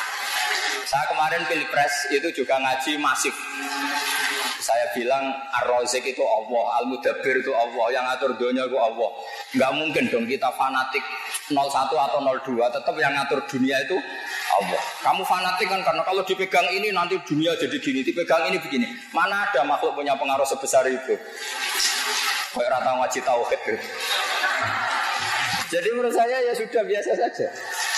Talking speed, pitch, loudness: 140 wpm, 155 Hz, -23 LUFS